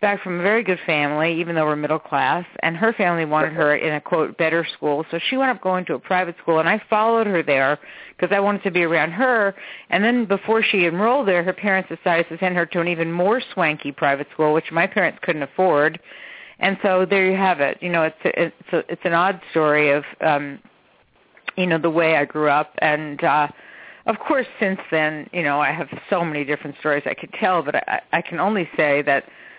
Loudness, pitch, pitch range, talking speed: -20 LUFS, 170 Hz, 155-190 Hz, 235 wpm